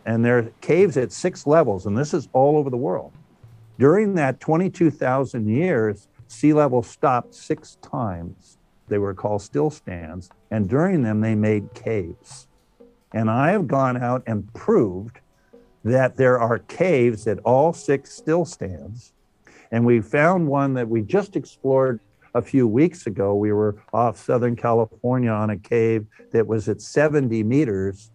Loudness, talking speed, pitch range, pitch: -21 LUFS, 155 wpm, 110-140 Hz, 120 Hz